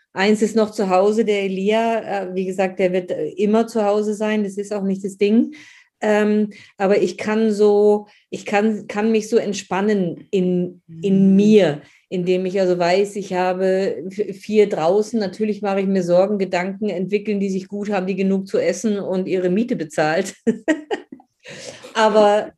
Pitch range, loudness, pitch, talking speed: 190-215 Hz, -19 LUFS, 205 Hz, 165 wpm